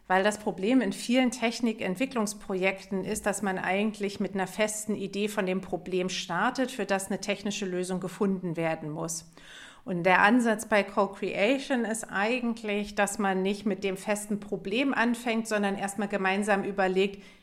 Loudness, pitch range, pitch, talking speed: -28 LUFS, 190-215 Hz, 200 Hz, 155 wpm